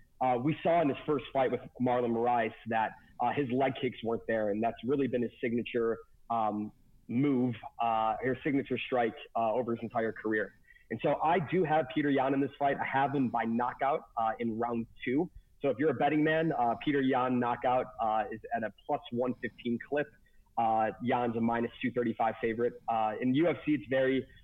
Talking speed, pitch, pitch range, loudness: 200 wpm, 125 Hz, 115-135 Hz, -32 LUFS